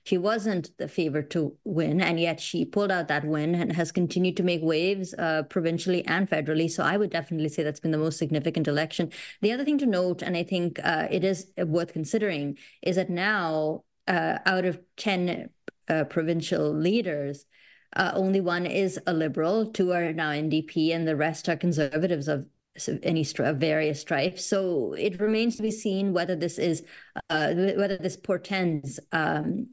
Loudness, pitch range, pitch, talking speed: -27 LUFS, 160-190 Hz, 175 Hz, 185 wpm